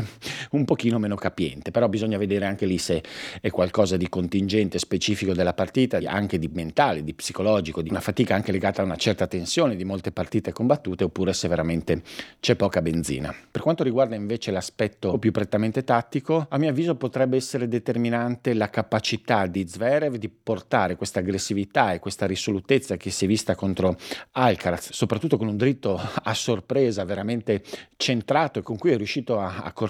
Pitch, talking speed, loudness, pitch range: 105 Hz, 175 wpm, -25 LUFS, 95-120 Hz